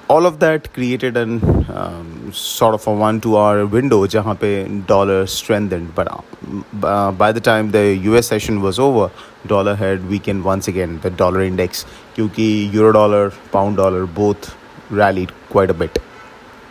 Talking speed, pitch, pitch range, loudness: 145 wpm, 100 Hz, 95-110 Hz, -16 LUFS